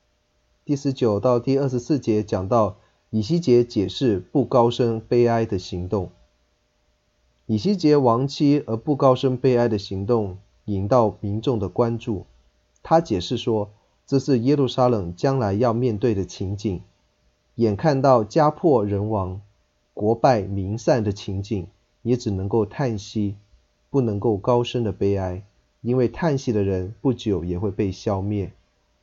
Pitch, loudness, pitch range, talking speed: 110 Hz, -22 LUFS, 95-125 Hz, 215 characters per minute